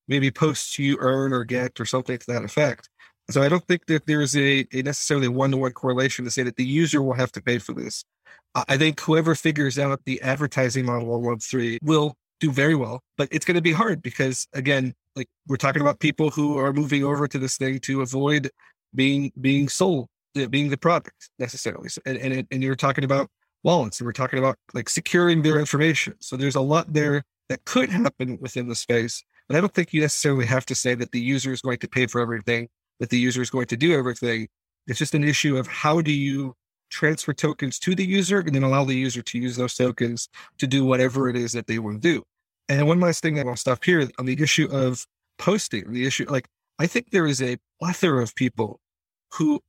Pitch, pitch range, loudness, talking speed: 135 Hz, 125-150 Hz, -23 LUFS, 230 wpm